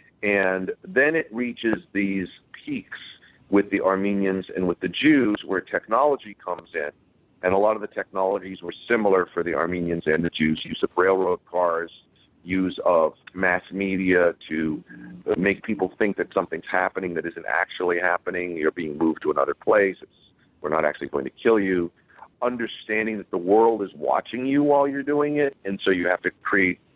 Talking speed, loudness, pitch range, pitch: 180 wpm, -23 LUFS, 90-110 Hz, 95 Hz